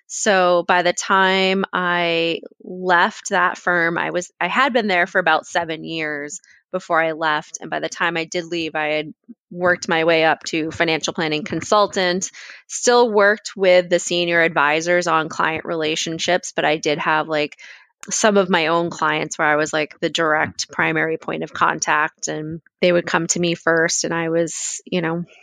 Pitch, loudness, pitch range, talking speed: 170 Hz, -19 LUFS, 160-180 Hz, 185 wpm